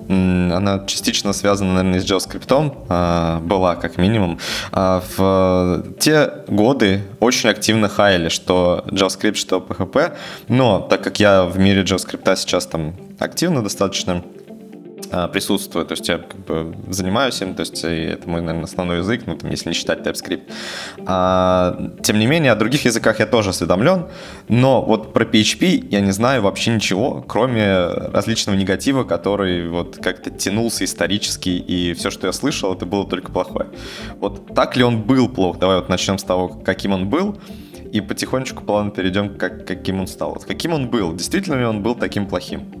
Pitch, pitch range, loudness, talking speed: 95 Hz, 90-110 Hz, -18 LUFS, 165 wpm